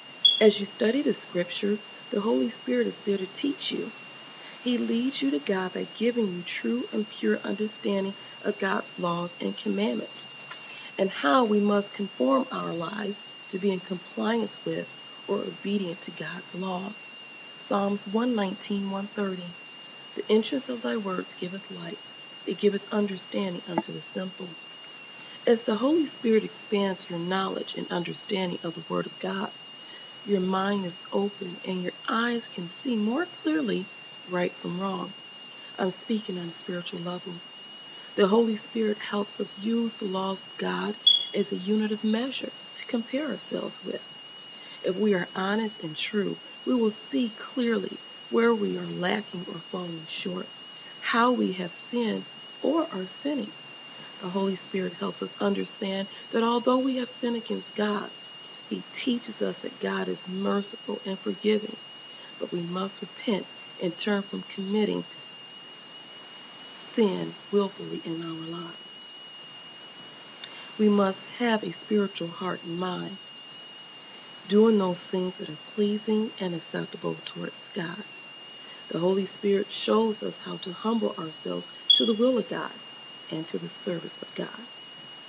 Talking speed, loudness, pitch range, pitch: 150 wpm, -28 LUFS, 185-220 Hz, 200 Hz